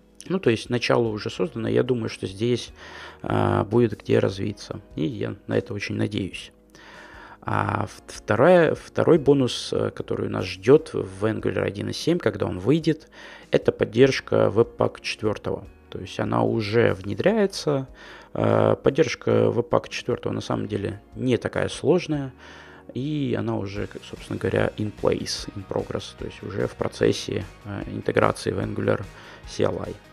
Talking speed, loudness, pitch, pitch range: 135 wpm, -24 LUFS, 115 Hz, 105-135 Hz